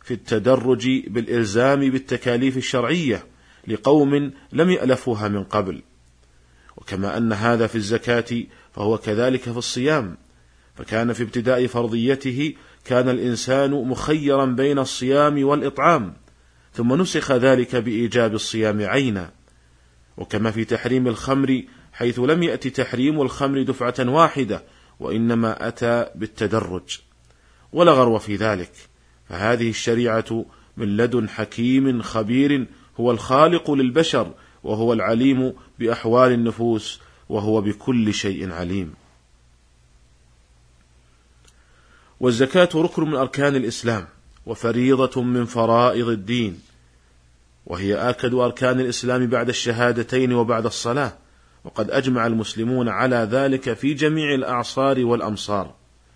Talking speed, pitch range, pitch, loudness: 105 wpm, 100-130 Hz, 120 Hz, -20 LUFS